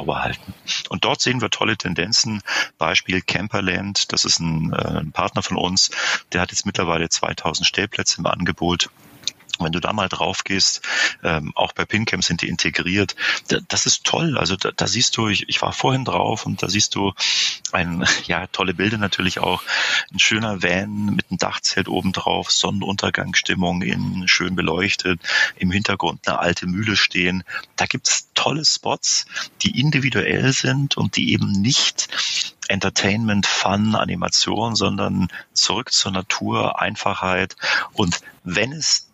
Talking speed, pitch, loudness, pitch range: 155 wpm, 95 Hz, -19 LUFS, 90-105 Hz